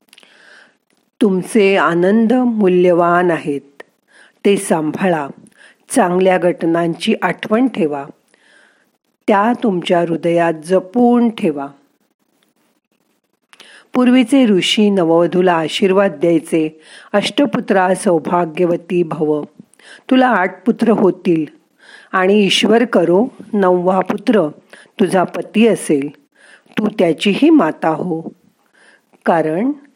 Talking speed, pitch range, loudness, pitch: 80 wpm, 170-225 Hz, -15 LUFS, 185 Hz